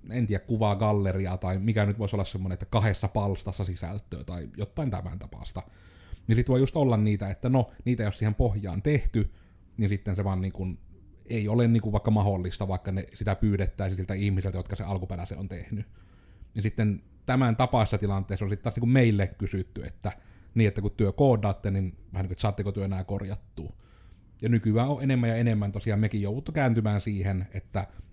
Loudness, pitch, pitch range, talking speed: -28 LUFS, 100 Hz, 95-110 Hz, 185 wpm